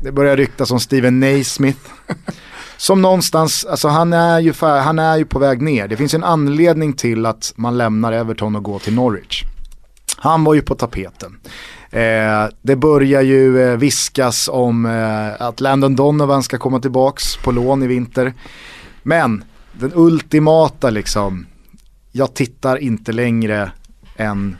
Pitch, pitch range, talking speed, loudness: 130 Hz, 115-145 Hz, 150 wpm, -15 LUFS